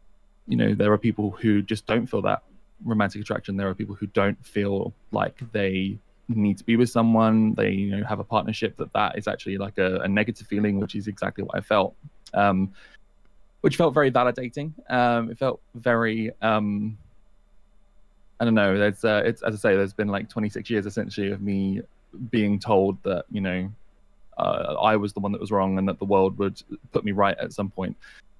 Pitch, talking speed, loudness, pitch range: 105 Hz, 205 wpm, -25 LUFS, 100-110 Hz